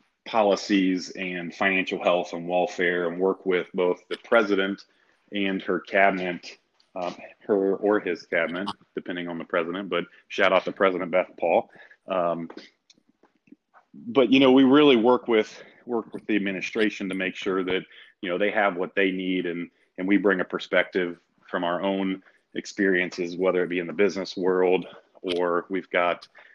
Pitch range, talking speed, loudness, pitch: 90-100 Hz, 165 wpm, -24 LUFS, 95 Hz